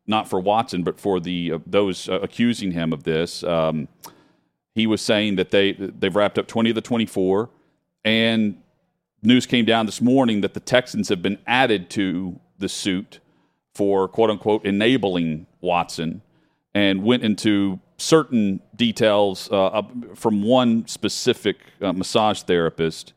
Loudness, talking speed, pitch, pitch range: -21 LUFS, 150 wpm, 105 Hz, 95-115 Hz